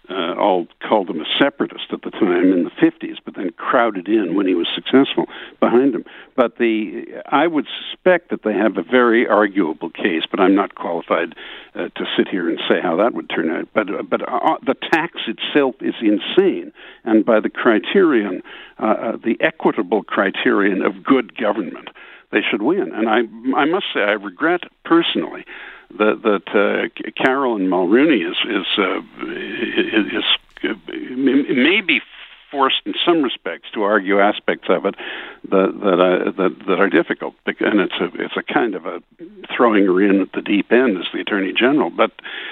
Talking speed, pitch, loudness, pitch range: 185 wpm, 330 Hz, -18 LUFS, 305-350 Hz